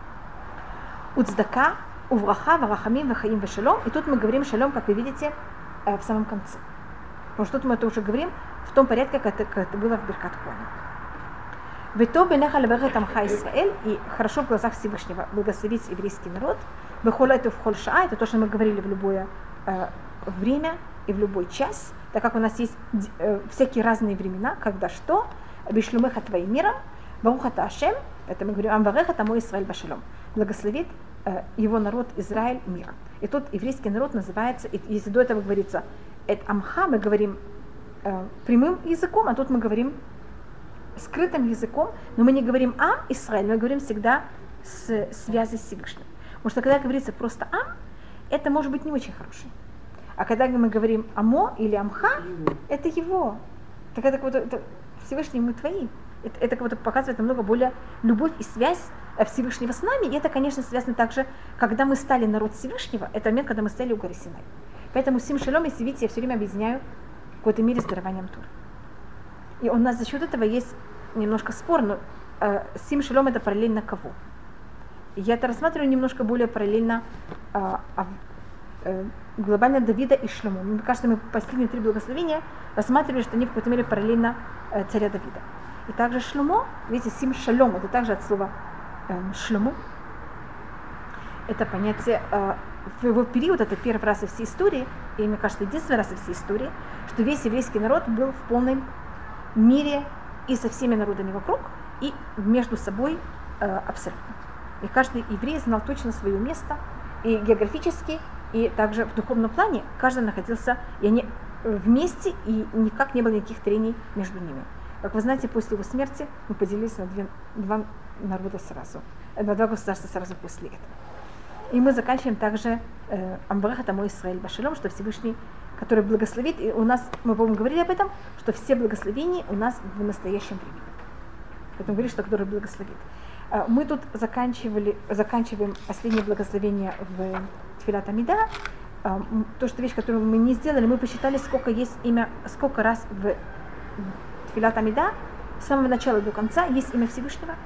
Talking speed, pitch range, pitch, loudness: 165 wpm, 210-255 Hz, 230 Hz, -25 LUFS